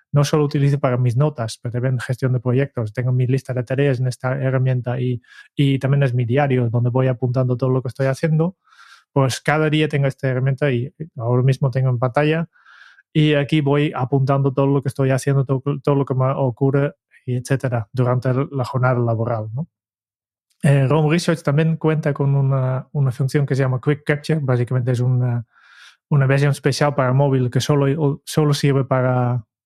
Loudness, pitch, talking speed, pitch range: -19 LUFS, 135 Hz, 190 wpm, 125-145 Hz